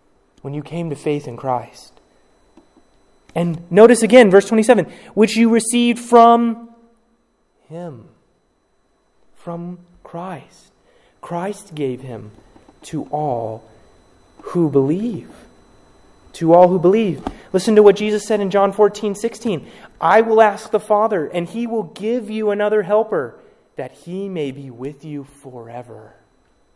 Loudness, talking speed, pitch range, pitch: -16 LUFS, 130 wpm, 140-220 Hz, 180 Hz